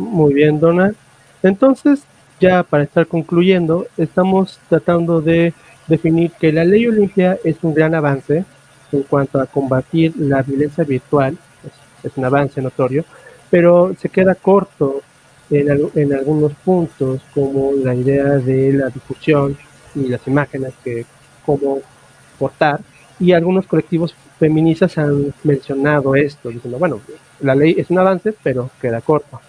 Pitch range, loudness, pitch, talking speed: 135-170 Hz, -15 LUFS, 145 Hz, 140 wpm